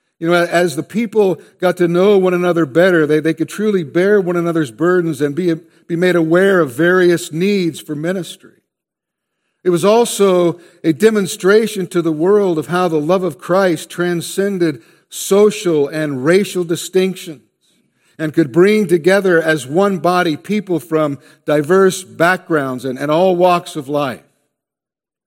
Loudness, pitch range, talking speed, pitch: -15 LUFS, 160-190 Hz, 155 wpm, 175 Hz